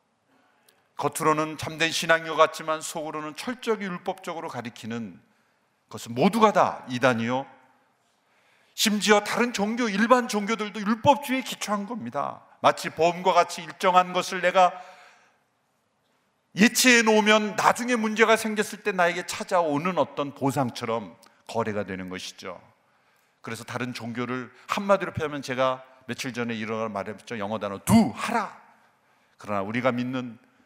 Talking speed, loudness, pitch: 305 characters per minute, -25 LUFS, 165 Hz